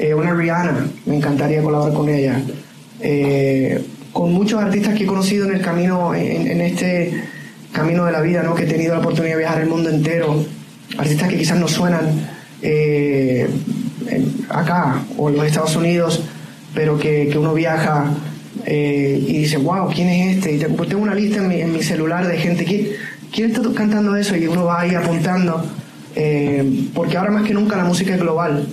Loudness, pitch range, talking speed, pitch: -18 LUFS, 150-180 Hz, 190 wpm, 165 Hz